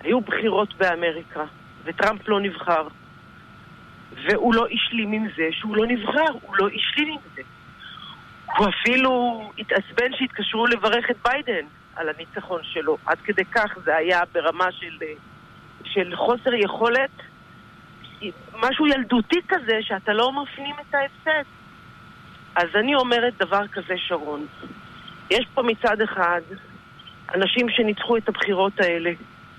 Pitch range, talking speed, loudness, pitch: 170-240 Hz, 125 wpm, -22 LUFS, 205 Hz